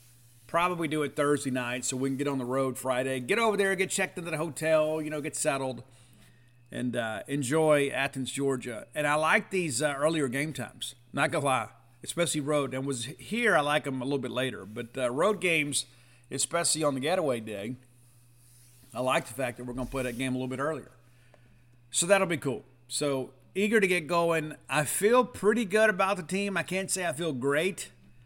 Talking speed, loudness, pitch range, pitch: 210 wpm, -29 LUFS, 125-160 Hz, 135 Hz